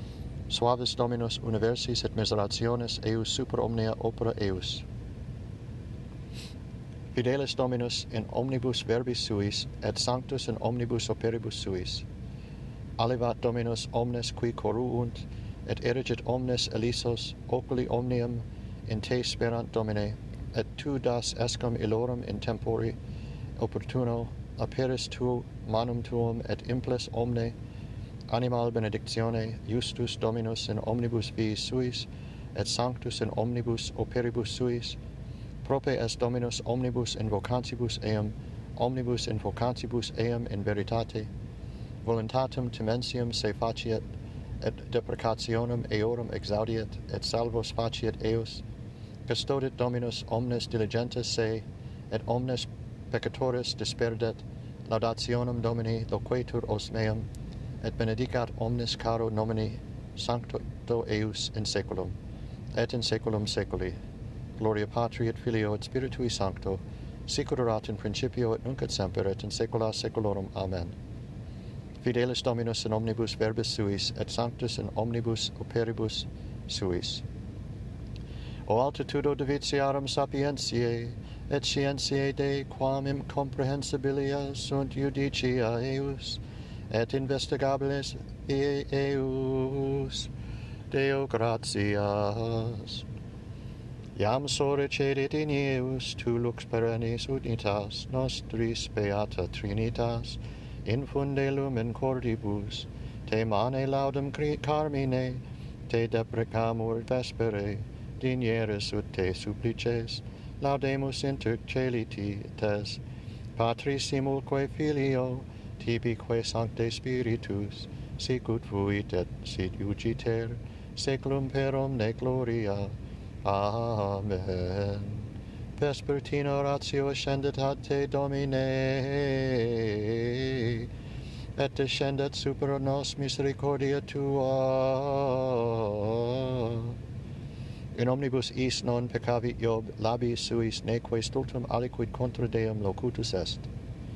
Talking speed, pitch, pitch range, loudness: 100 wpm, 115 Hz, 110-125 Hz, -31 LUFS